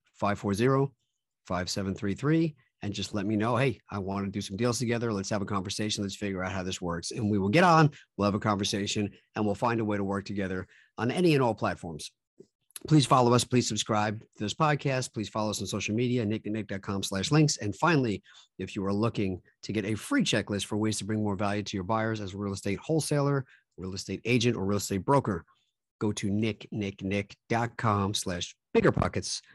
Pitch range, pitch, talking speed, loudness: 100-120 Hz, 105 Hz, 205 wpm, -29 LUFS